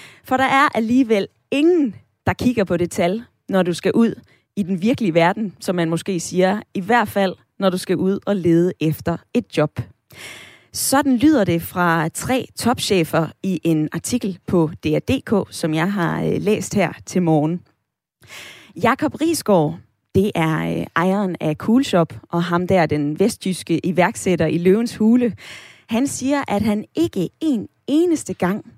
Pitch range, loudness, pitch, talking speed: 165-230 Hz, -19 LUFS, 190 Hz, 160 wpm